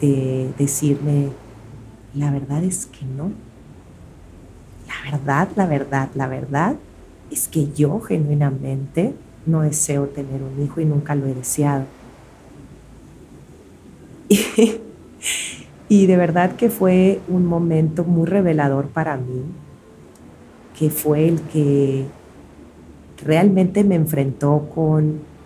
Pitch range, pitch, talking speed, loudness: 135-165 Hz, 145 Hz, 110 wpm, -19 LUFS